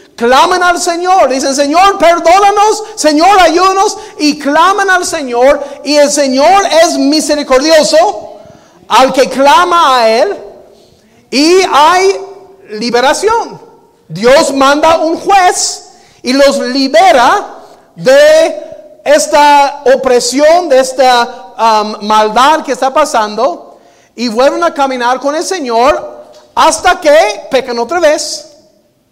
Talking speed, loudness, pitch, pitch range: 110 wpm, -8 LUFS, 305 Hz, 265-355 Hz